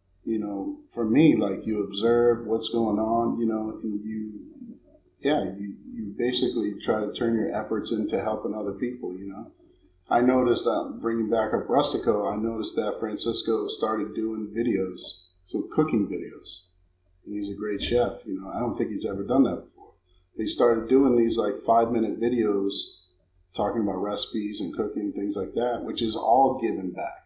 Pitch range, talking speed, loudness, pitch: 100-115 Hz, 180 wpm, -26 LUFS, 110 Hz